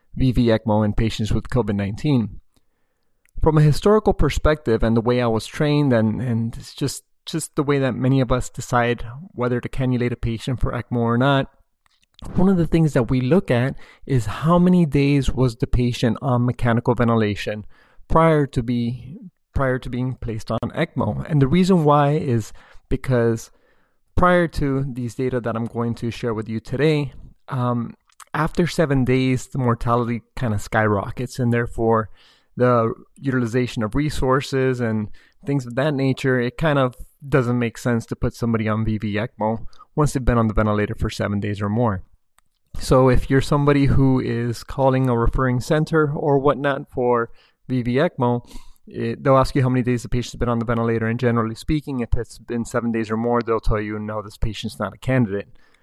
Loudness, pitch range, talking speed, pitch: -21 LUFS, 115-135 Hz, 185 wpm, 125 Hz